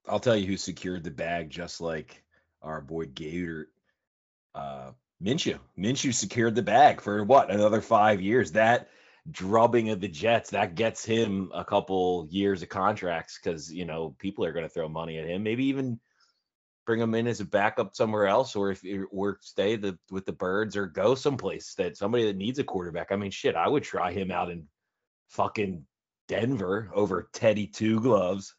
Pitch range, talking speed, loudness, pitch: 85-110 Hz, 190 wpm, -27 LUFS, 100 Hz